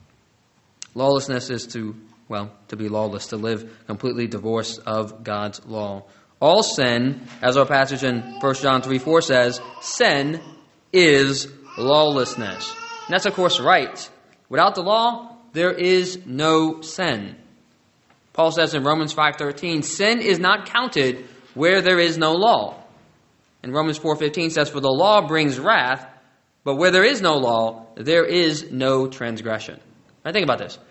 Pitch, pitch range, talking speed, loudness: 135 Hz, 120-165 Hz, 155 wpm, -20 LUFS